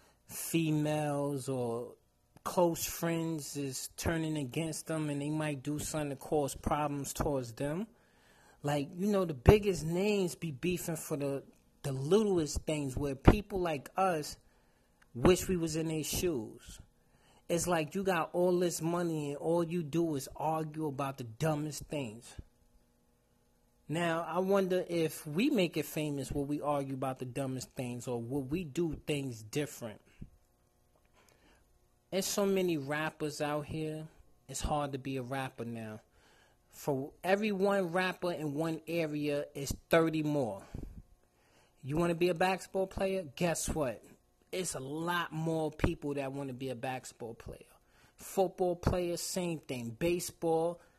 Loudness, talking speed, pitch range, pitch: -34 LUFS, 150 wpm, 135-170 Hz, 155 Hz